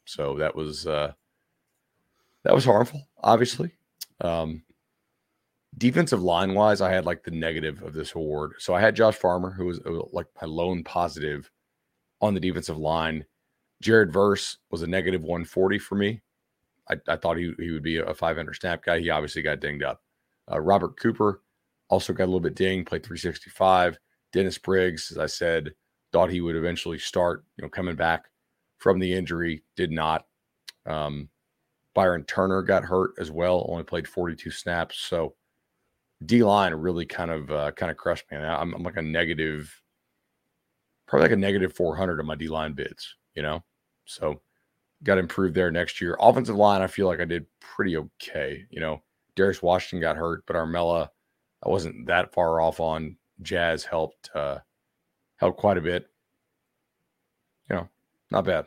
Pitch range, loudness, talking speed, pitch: 80-95 Hz, -26 LUFS, 180 wpm, 85 Hz